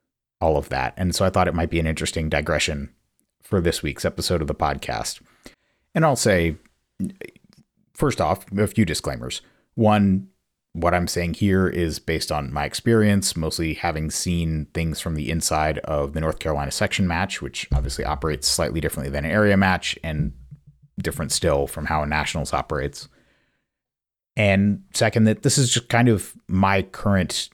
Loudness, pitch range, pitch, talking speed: -22 LUFS, 80-100 Hz, 85 Hz, 170 wpm